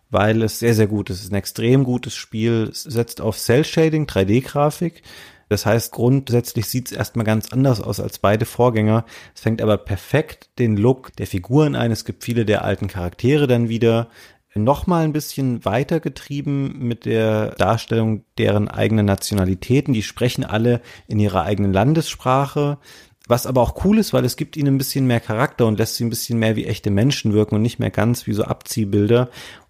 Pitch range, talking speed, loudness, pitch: 105-130 Hz, 190 wpm, -19 LUFS, 115 Hz